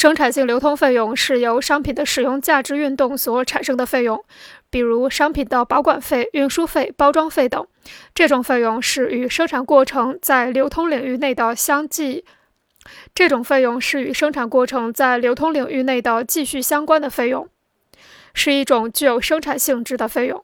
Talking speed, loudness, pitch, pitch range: 275 characters per minute, -18 LUFS, 270 Hz, 250-290 Hz